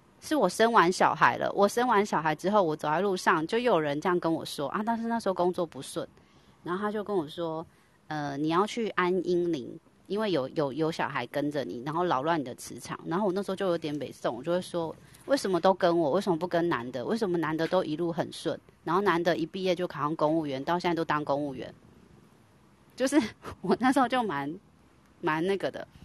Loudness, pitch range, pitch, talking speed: -29 LUFS, 155-195 Hz, 175 Hz, 325 characters per minute